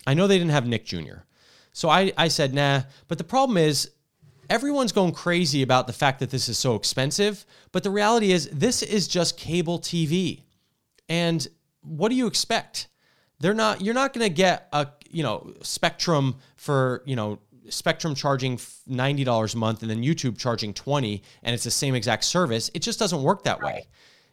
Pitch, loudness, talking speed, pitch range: 150 Hz, -24 LUFS, 185 wpm, 130-185 Hz